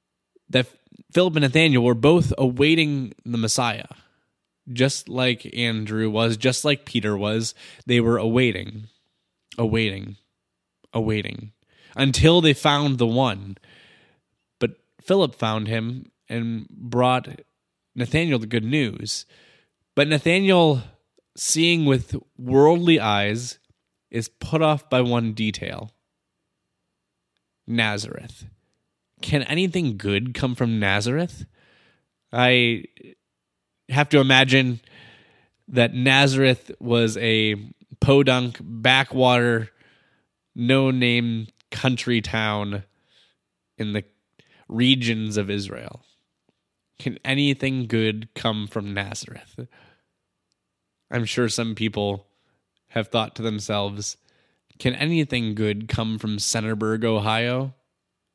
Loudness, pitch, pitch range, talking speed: -21 LUFS, 115 Hz, 105-130 Hz, 100 wpm